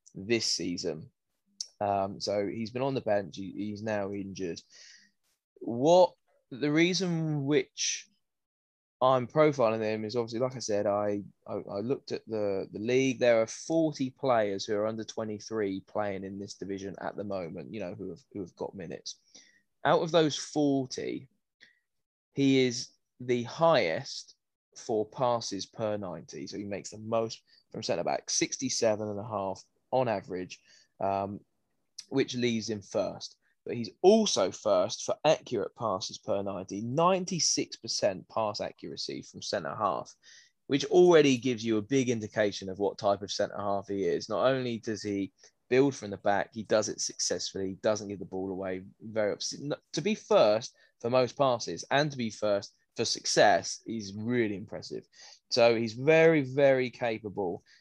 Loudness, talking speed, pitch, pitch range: -30 LUFS, 160 wpm, 110 Hz, 100-135 Hz